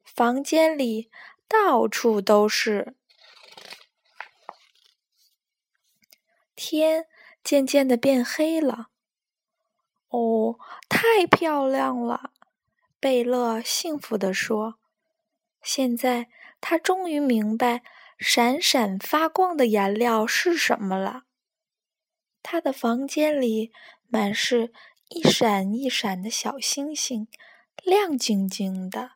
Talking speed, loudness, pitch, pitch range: 130 characters per minute, -23 LUFS, 250 Hz, 220-310 Hz